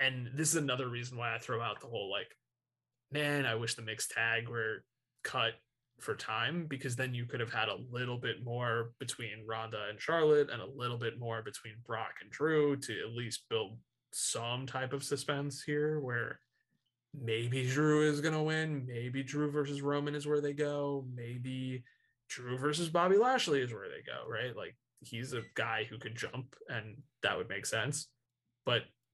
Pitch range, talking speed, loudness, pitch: 115-145 Hz, 190 wpm, -35 LUFS, 125 Hz